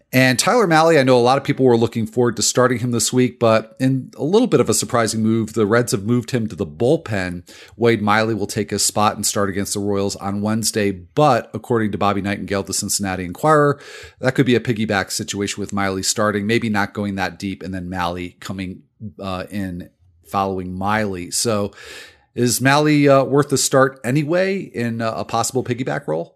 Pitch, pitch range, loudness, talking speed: 110 Hz, 100-125 Hz, -18 LUFS, 205 wpm